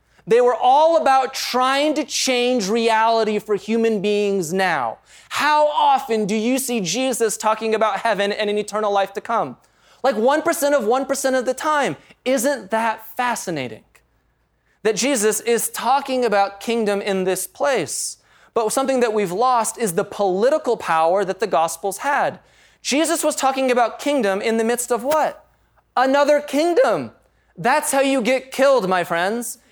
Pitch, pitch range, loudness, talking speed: 235 Hz, 210-270 Hz, -19 LUFS, 155 wpm